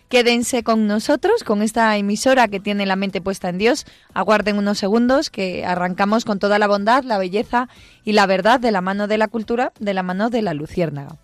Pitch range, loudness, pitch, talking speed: 195-235 Hz, -18 LUFS, 210 Hz, 210 wpm